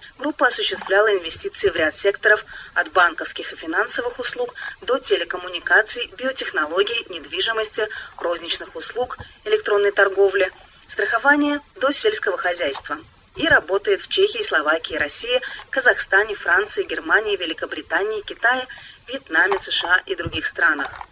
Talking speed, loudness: 110 wpm, -20 LUFS